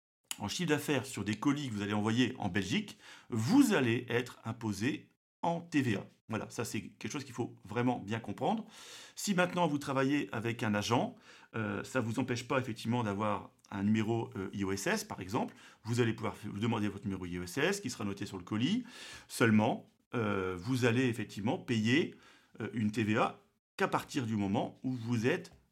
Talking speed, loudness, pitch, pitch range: 185 wpm, -34 LUFS, 115 Hz, 105-130 Hz